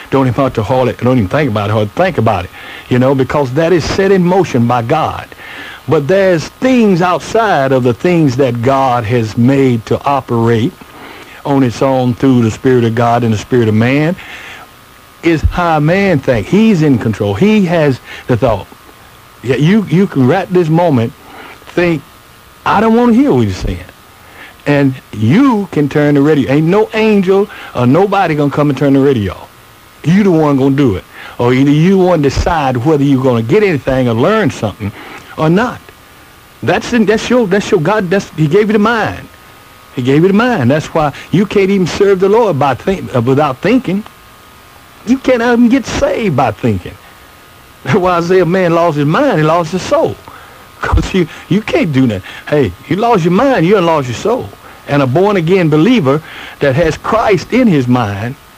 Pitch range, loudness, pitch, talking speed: 120-185 Hz, -11 LUFS, 140 Hz, 200 wpm